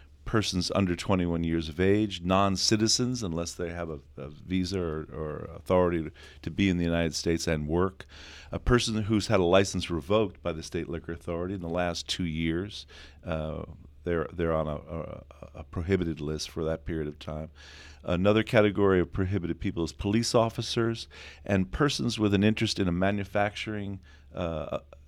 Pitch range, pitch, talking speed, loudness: 80-100 Hz, 85 Hz, 170 wpm, -28 LUFS